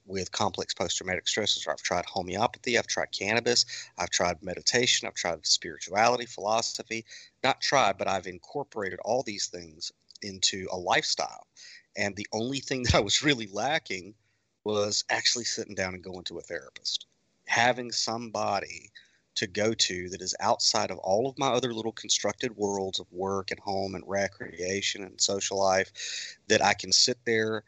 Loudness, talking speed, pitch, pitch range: -28 LUFS, 165 wpm, 105 Hz, 95-115 Hz